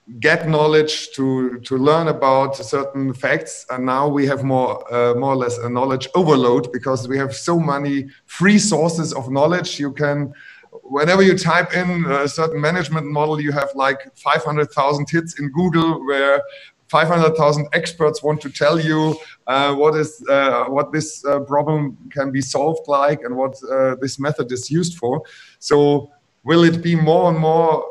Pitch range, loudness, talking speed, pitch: 135-160 Hz, -18 LUFS, 180 wpm, 145 Hz